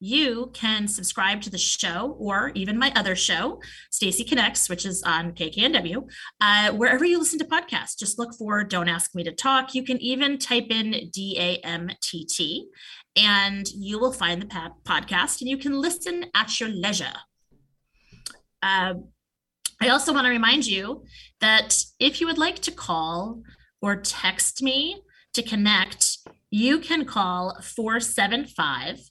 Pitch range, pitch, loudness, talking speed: 185-265 Hz, 215 Hz, -23 LUFS, 160 wpm